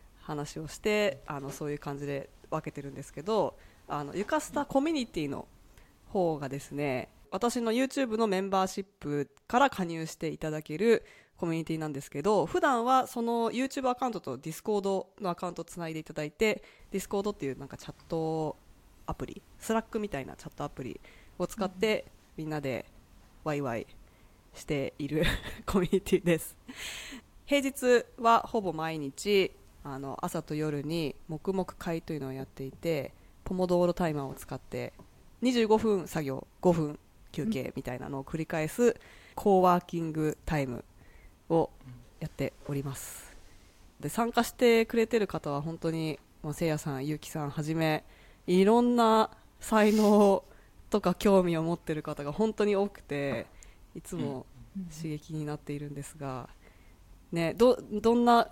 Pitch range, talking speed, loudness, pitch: 145-210 Hz, 330 characters per minute, -31 LUFS, 165 Hz